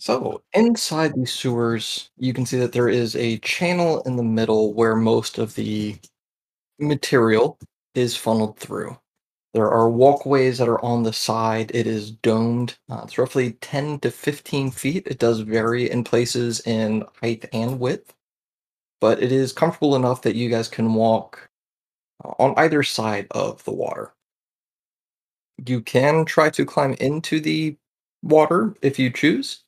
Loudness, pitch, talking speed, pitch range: -21 LUFS, 125 Hz, 155 wpm, 115-145 Hz